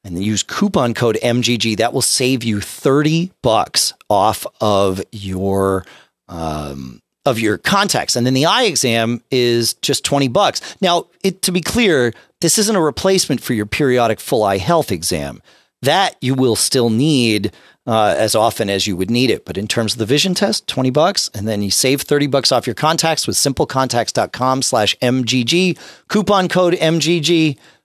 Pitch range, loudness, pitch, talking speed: 110-155 Hz, -16 LUFS, 125 Hz, 175 wpm